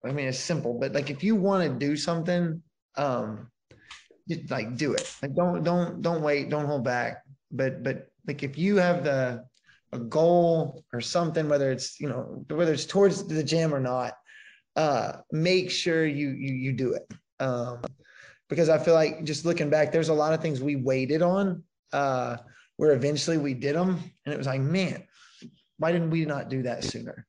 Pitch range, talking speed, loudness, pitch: 135-170 Hz, 195 wpm, -27 LUFS, 150 Hz